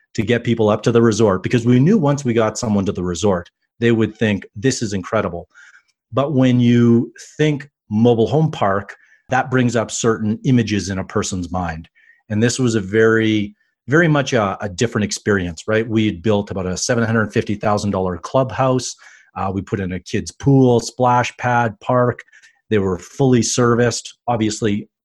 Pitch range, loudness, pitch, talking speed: 105-120 Hz, -18 LUFS, 110 Hz, 175 wpm